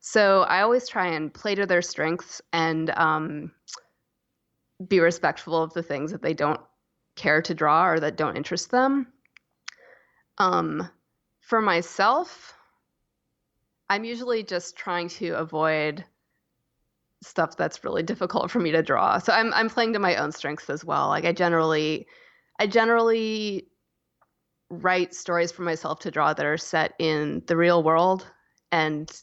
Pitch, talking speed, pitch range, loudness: 175 Hz, 150 wpm, 160-210 Hz, -24 LUFS